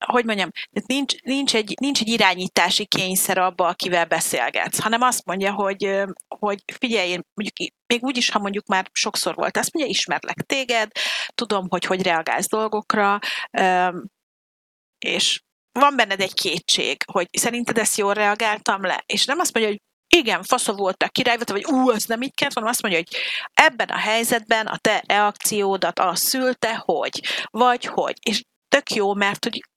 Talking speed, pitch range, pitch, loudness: 165 wpm, 195-245 Hz, 215 Hz, -21 LUFS